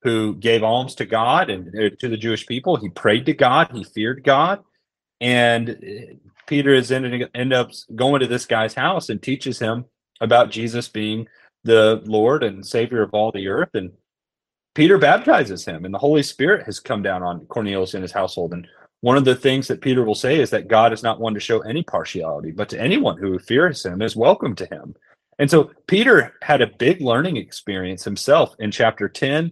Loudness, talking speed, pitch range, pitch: -19 LUFS, 200 wpm, 105-130 Hz, 115 Hz